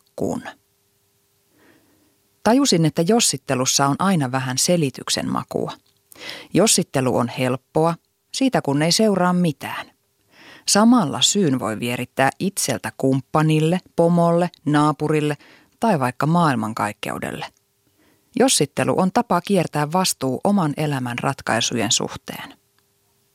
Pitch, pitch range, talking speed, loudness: 150 Hz, 130-180 Hz, 95 wpm, -19 LUFS